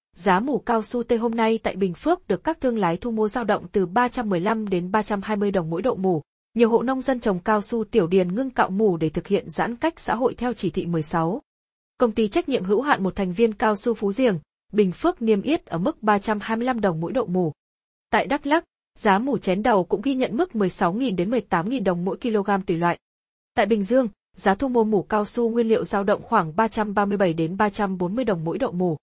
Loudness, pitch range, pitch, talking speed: -23 LUFS, 190-240 Hz, 215 Hz, 235 wpm